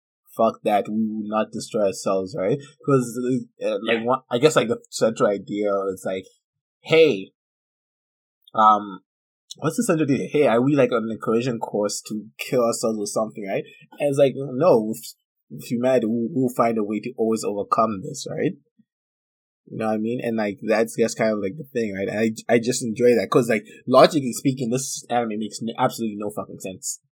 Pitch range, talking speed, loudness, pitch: 110-130 Hz, 200 wpm, -22 LUFS, 115 Hz